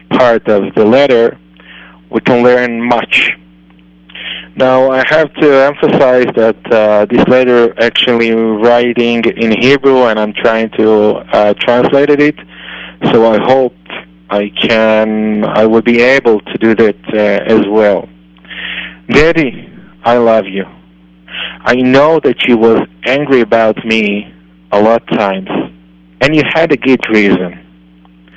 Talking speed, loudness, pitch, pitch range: 140 wpm, -9 LUFS, 110 Hz, 95-125 Hz